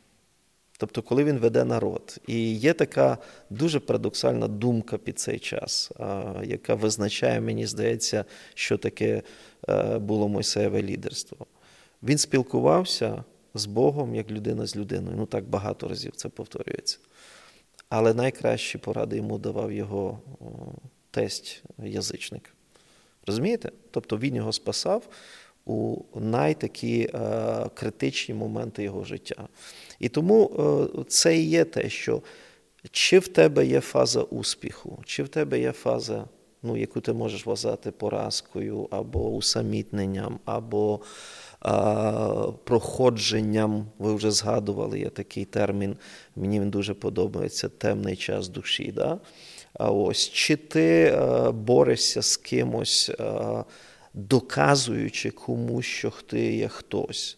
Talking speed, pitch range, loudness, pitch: 115 wpm, 100-125 Hz, -26 LUFS, 110 Hz